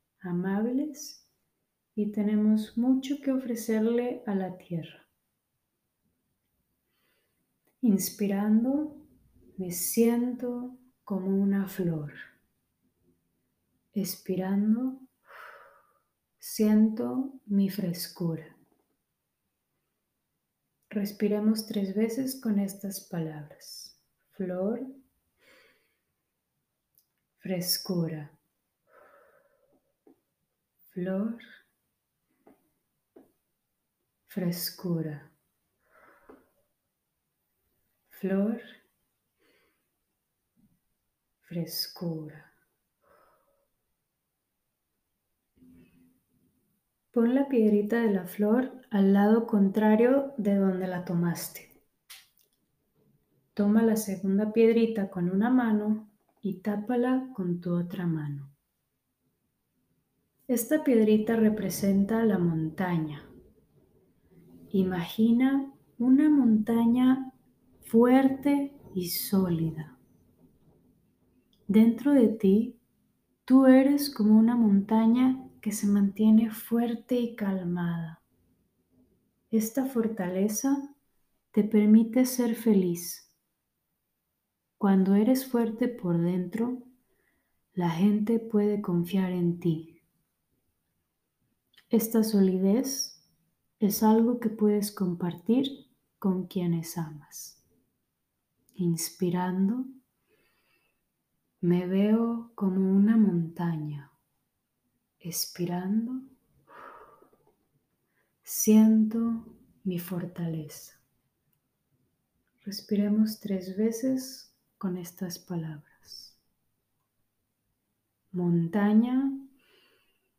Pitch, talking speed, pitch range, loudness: 205 Hz, 65 wpm, 175-230 Hz, -27 LUFS